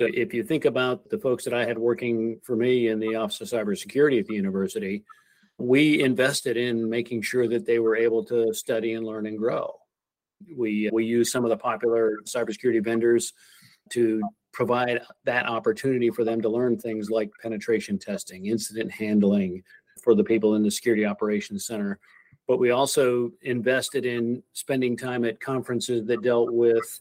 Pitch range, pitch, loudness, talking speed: 110-120 Hz, 115 Hz, -25 LUFS, 175 wpm